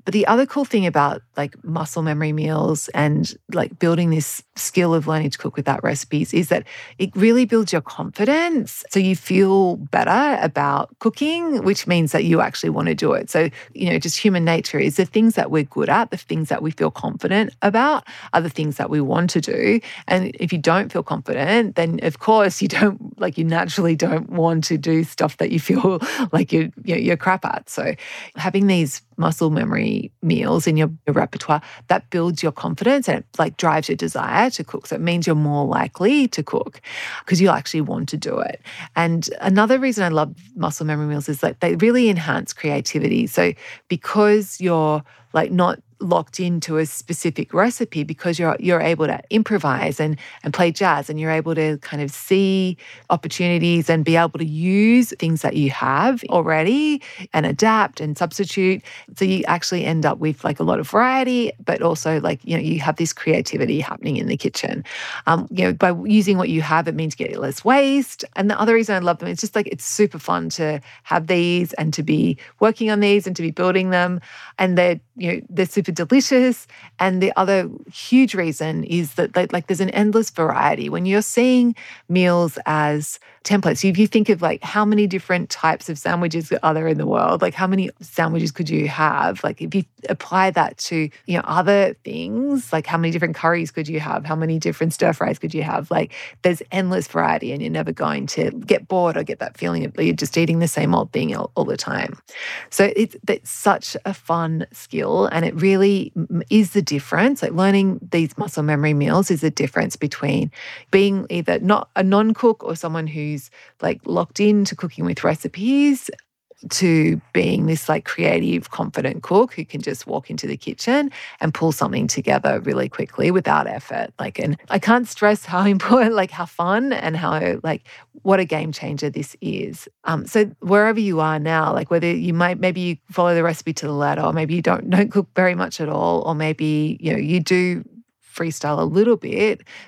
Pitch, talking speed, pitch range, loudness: 175 Hz, 205 wpm, 160-200 Hz, -20 LUFS